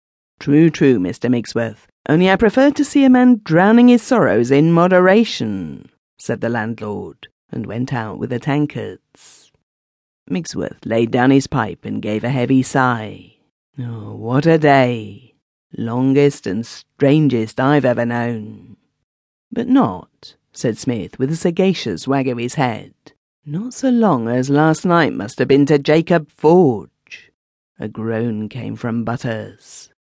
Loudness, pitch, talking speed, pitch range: -16 LUFS, 130 Hz, 145 wpm, 115-160 Hz